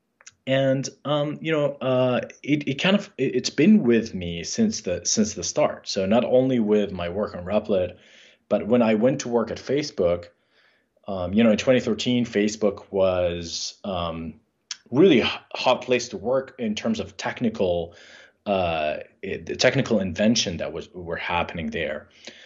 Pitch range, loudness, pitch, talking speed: 95-135 Hz, -23 LUFS, 120 Hz, 170 wpm